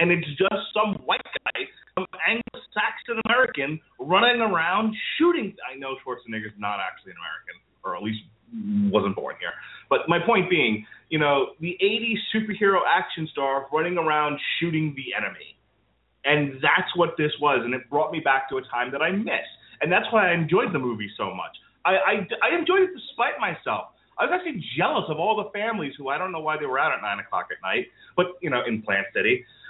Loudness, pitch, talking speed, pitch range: -24 LUFS, 165 Hz, 205 wpm, 135-210 Hz